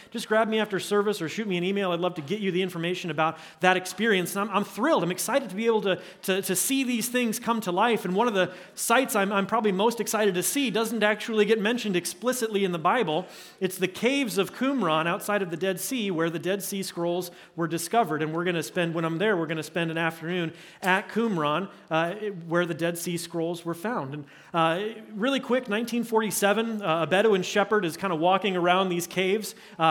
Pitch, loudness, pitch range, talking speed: 190 Hz, -26 LUFS, 175-215 Hz, 235 wpm